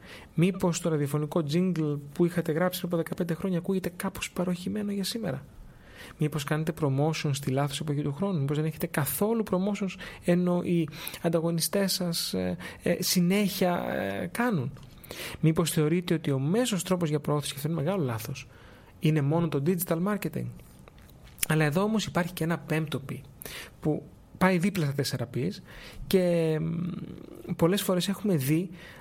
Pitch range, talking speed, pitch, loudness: 145-185 Hz, 150 wpm, 170 Hz, -28 LUFS